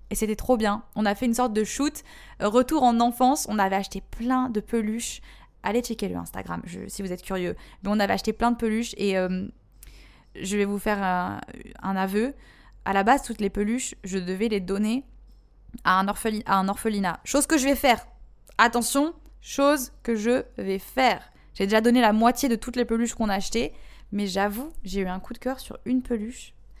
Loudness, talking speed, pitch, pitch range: -25 LUFS, 215 wpm, 225 Hz, 200-245 Hz